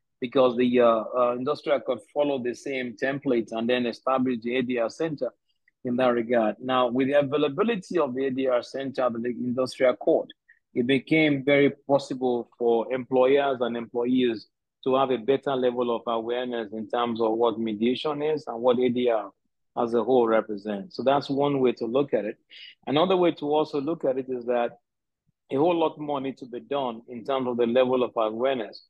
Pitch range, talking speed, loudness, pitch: 120-140 Hz, 185 wpm, -25 LUFS, 125 Hz